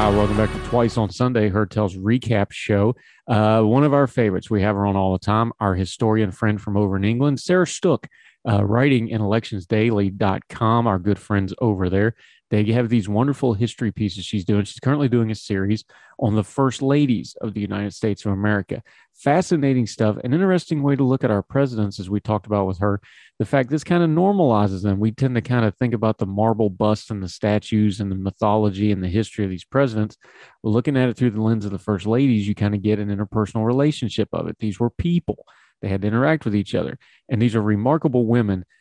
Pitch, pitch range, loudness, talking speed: 110 Hz, 105-120 Hz, -21 LUFS, 220 wpm